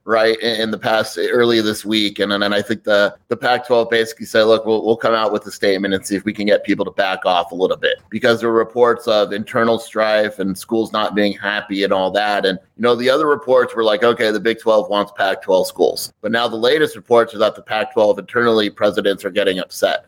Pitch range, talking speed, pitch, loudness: 105-115 Hz, 250 wpm, 110 Hz, -17 LUFS